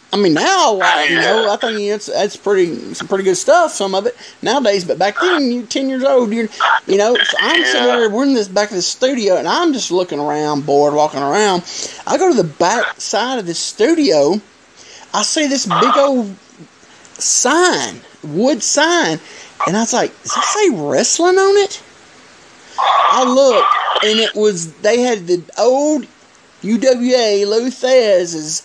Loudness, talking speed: -14 LUFS, 180 wpm